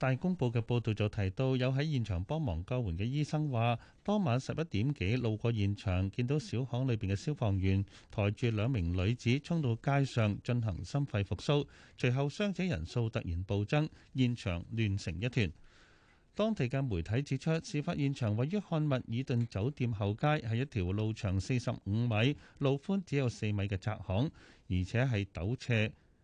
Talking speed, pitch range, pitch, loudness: 270 characters per minute, 105-140 Hz, 120 Hz, -34 LUFS